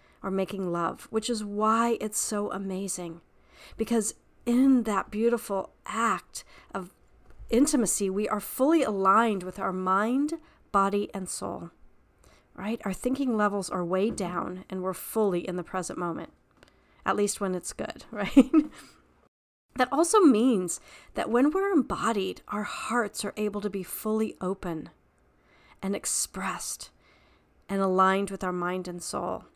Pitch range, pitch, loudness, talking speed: 185-230 Hz, 200 Hz, -28 LUFS, 140 wpm